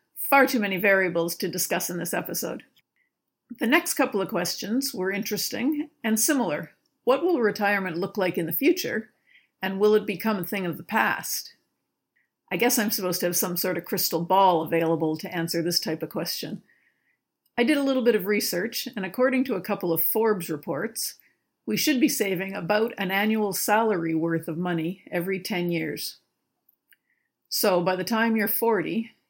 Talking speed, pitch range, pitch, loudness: 180 wpm, 175-230 Hz, 200 Hz, -25 LUFS